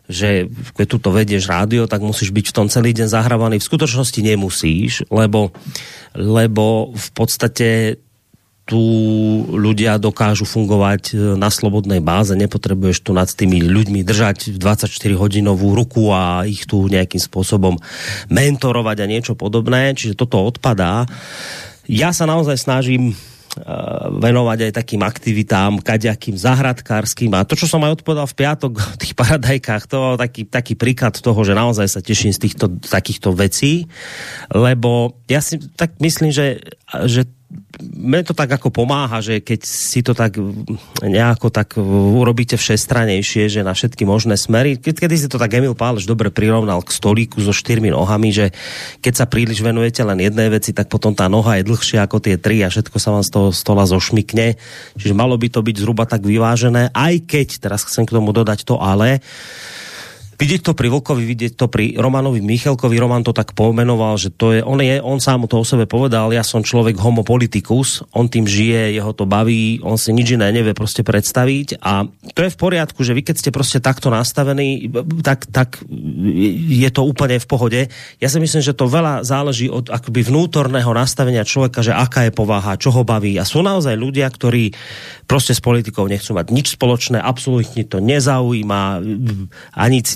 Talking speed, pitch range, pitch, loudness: 175 wpm, 105-130 Hz, 115 Hz, -15 LUFS